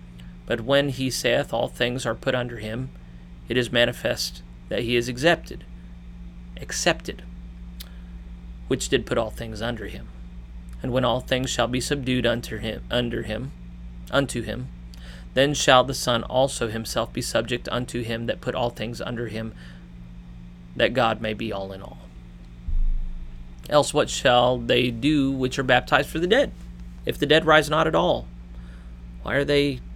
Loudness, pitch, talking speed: -23 LUFS, 110 Hz, 165 wpm